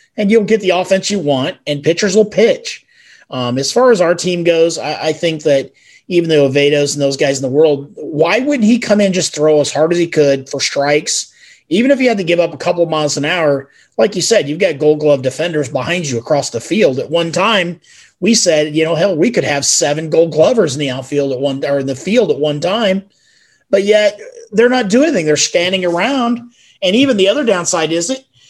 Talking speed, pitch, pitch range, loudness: 240 wpm, 170 Hz, 145-210 Hz, -13 LUFS